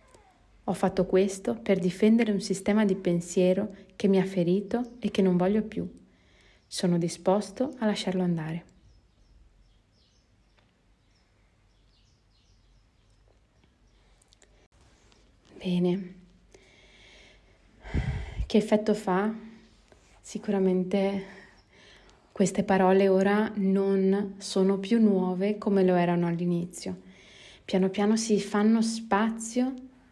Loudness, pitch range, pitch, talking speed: -27 LUFS, 170-205 Hz, 190 Hz, 90 wpm